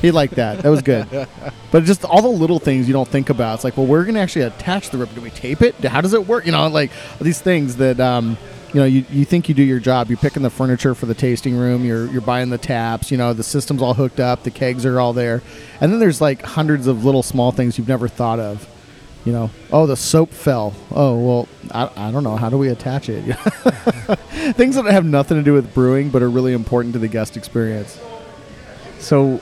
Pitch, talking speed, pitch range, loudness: 130 Hz, 245 wpm, 120-150 Hz, -17 LUFS